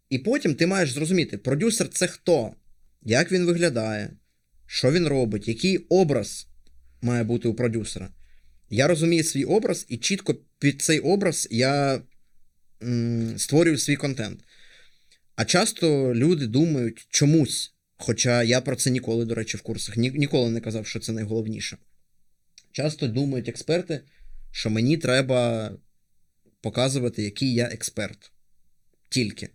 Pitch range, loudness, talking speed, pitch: 110-150 Hz, -24 LUFS, 135 wpm, 120 Hz